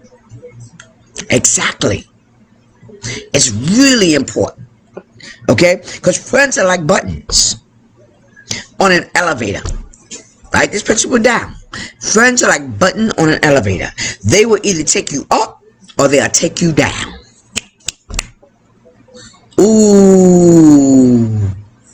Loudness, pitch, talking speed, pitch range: -11 LUFS, 145 Hz, 100 wpm, 115-190 Hz